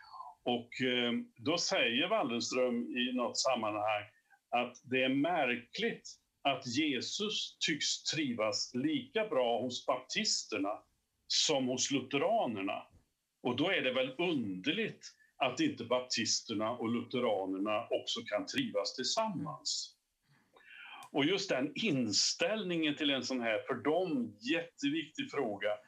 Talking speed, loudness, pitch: 115 wpm, -34 LUFS, 155 Hz